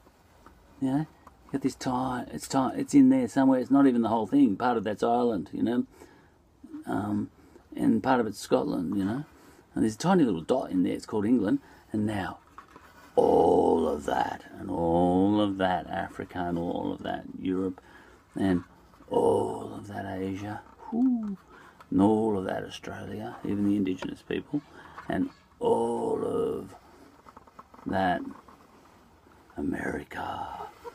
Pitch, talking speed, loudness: 125 Hz, 150 wpm, -28 LUFS